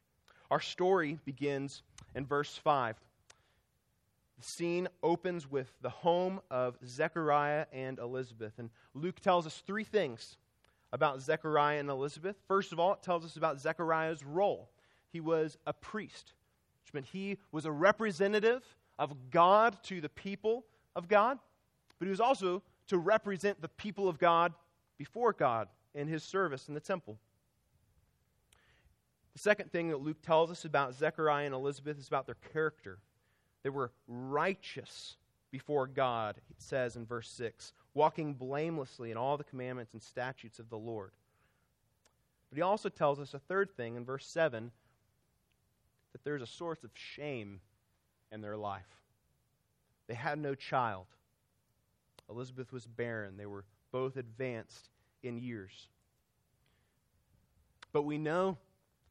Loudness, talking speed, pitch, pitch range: -35 LUFS, 145 wpm, 140 Hz, 120-170 Hz